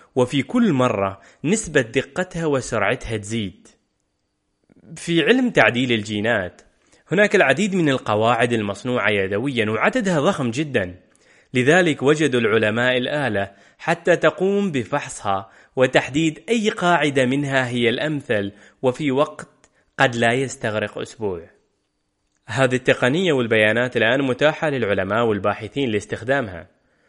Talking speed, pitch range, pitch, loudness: 105 wpm, 110-150 Hz, 130 Hz, -20 LUFS